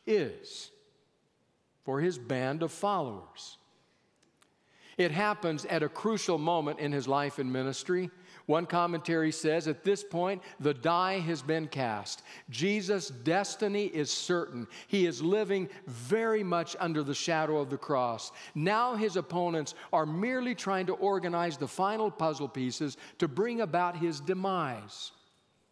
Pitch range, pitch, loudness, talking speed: 150-195 Hz, 170 Hz, -32 LUFS, 140 wpm